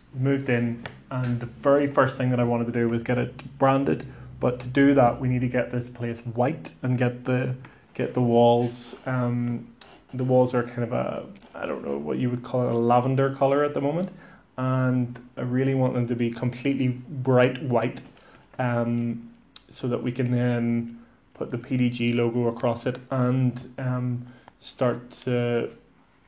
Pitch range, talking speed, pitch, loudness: 120-130 Hz, 185 wpm, 125 Hz, -25 LUFS